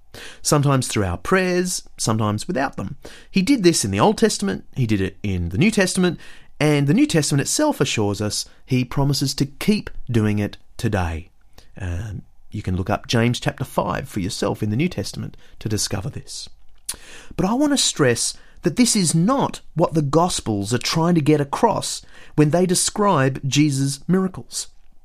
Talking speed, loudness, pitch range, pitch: 175 wpm, -20 LUFS, 105-175 Hz, 140 Hz